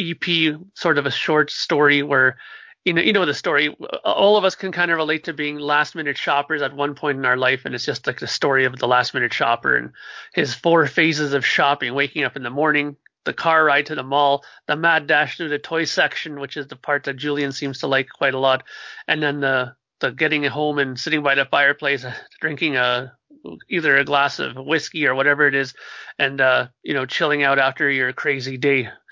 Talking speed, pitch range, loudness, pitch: 225 wpm, 135-155 Hz, -19 LUFS, 145 Hz